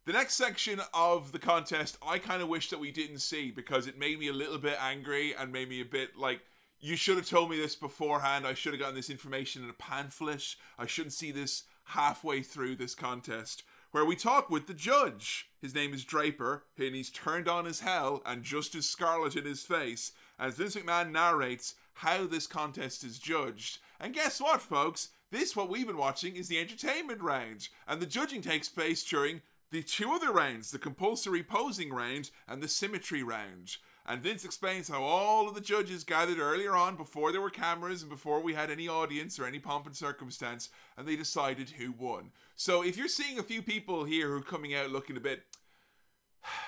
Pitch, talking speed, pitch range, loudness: 155 Hz, 205 wpm, 140-175 Hz, -34 LUFS